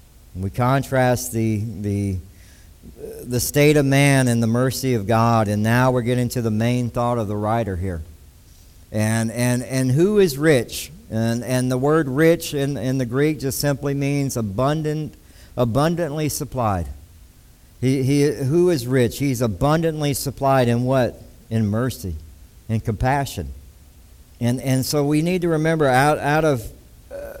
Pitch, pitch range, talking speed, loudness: 125 Hz, 105-140 Hz, 155 wpm, -20 LUFS